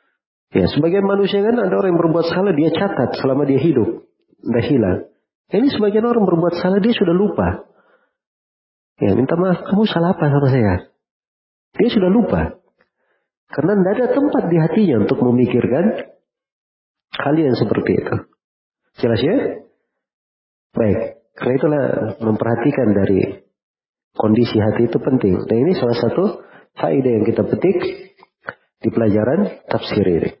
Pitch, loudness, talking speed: 170 Hz, -17 LUFS, 140 wpm